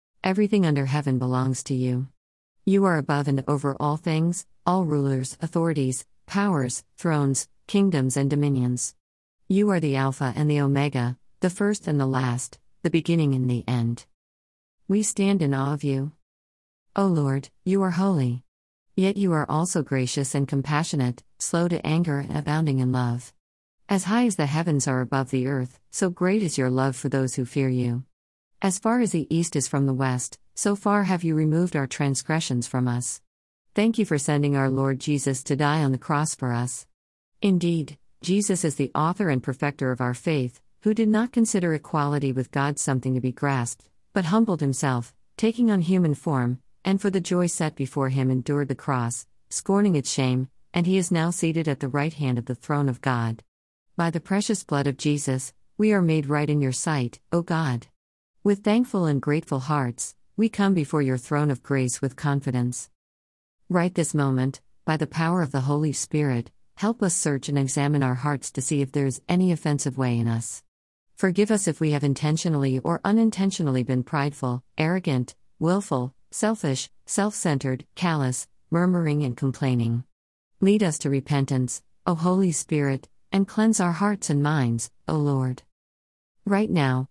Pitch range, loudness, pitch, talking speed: 130-170 Hz, -24 LUFS, 145 Hz, 180 wpm